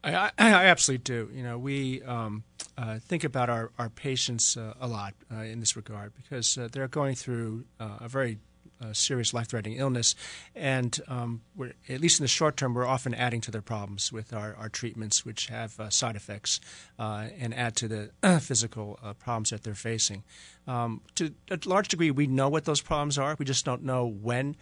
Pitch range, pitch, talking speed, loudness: 110-135 Hz, 120 Hz, 205 wpm, -28 LUFS